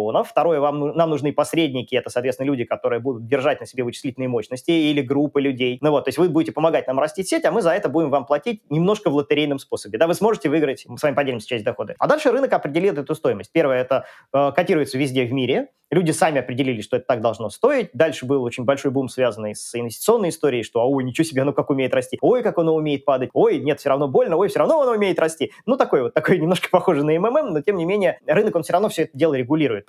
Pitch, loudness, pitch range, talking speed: 150 Hz, -20 LUFS, 130-165 Hz, 250 wpm